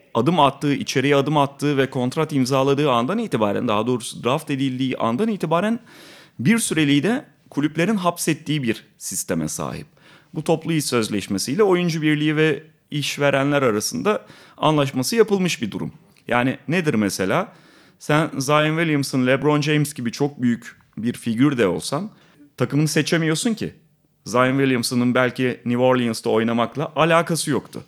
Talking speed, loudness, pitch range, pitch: 135 wpm, -21 LUFS, 130-155 Hz, 145 Hz